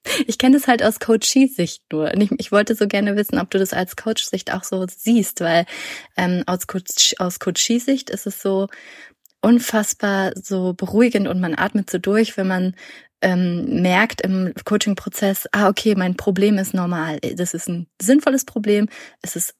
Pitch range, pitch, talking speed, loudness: 185-220 Hz, 200 Hz, 185 wpm, -19 LUFS